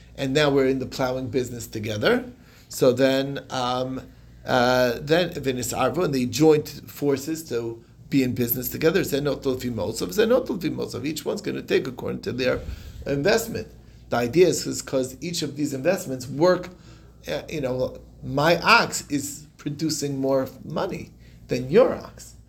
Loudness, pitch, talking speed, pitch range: -24 LUFS, 135 Hz, 135 wpm, 125-150 Hz